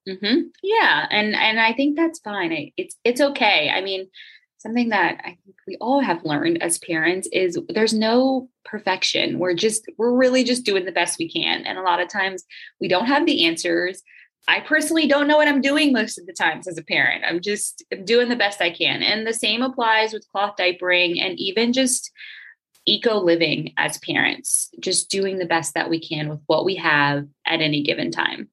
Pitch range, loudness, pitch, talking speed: 180-280 Hz, -20 LUFS, 215 Hz, 205 wpm